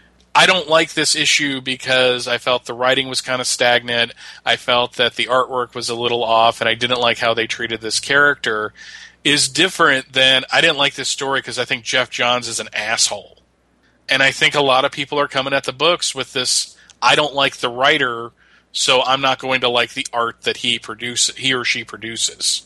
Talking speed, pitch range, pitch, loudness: 220 wpm, 120-135 Hz, 125 Hz, -16 LUFS